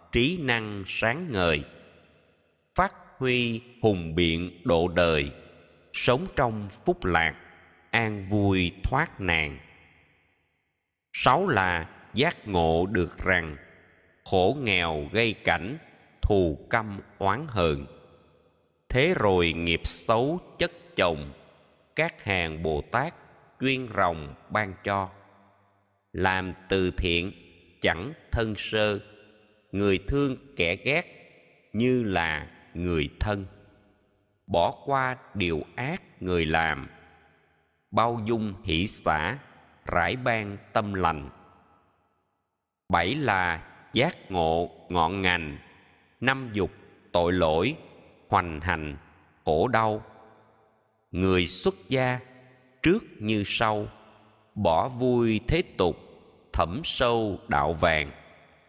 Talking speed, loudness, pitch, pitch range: 105 wpm, -27 LUFS, 100 Hz, 85-110 Hz